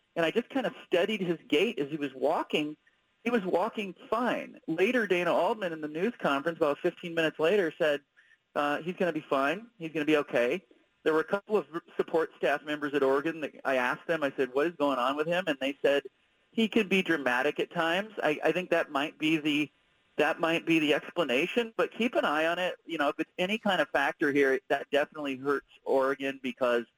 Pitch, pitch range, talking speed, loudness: 165 Hz, 145-200 Hz, 230 wpm, -29 LUFS